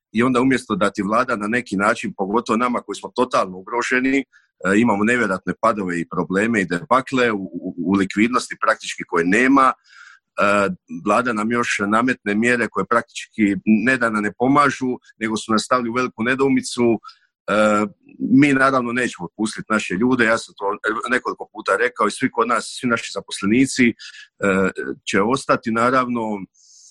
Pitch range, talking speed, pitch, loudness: 105-125 Hz, 150 wpm, 115 Hz, -19 LUFS